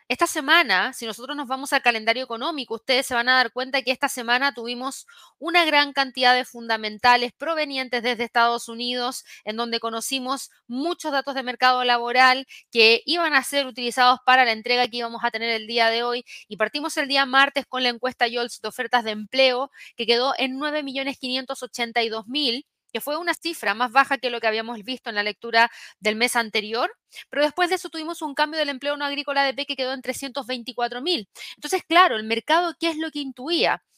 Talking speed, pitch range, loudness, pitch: 200 wpm, 235-280 Hz, -22 LUFS, 255 Hz